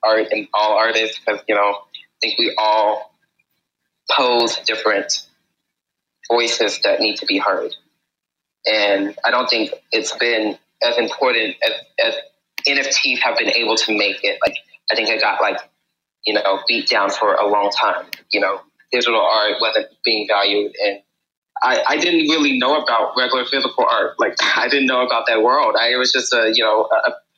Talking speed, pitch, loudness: 180 wpm, 125 Hz, -17 LUFS